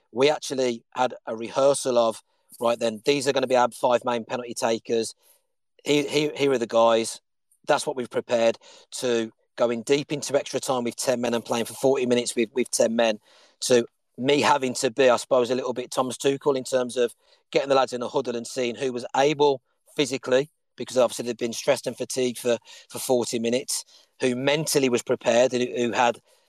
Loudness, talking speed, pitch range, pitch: -24 LUFS, 210 wpm, 120-135 Hz, 125 Hz